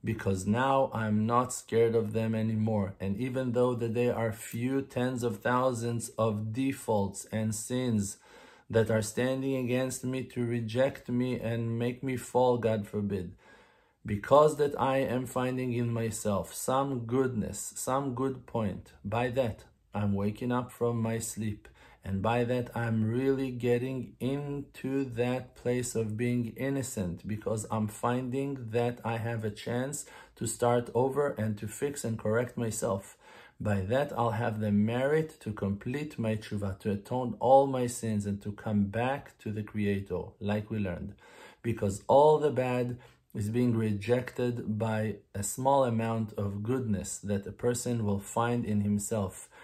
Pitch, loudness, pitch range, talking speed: 115 Hz, -31 LUFS, 105-125 Hz, 155 wpm